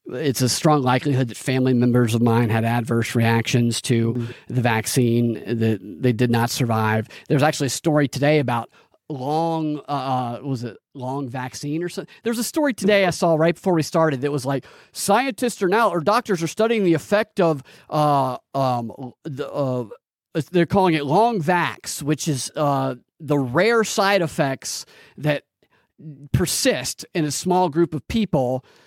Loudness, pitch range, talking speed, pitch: -21 LUFS, 125-170 Hz, 170 wpm, 145 Hz